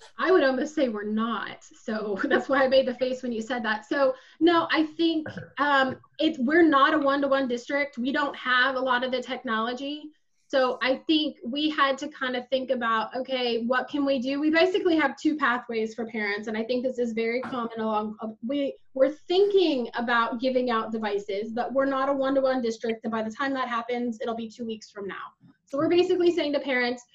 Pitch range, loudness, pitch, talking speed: 230-280 Hz, -26 LUFS, 260 Hz, 215 wpm